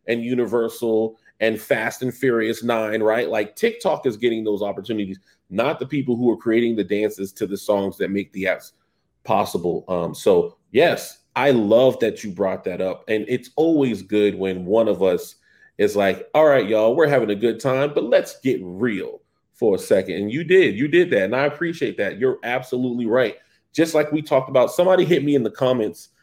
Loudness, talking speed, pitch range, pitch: -20 LUFS, 205 wpm, 110-165 Hz, 120 Hz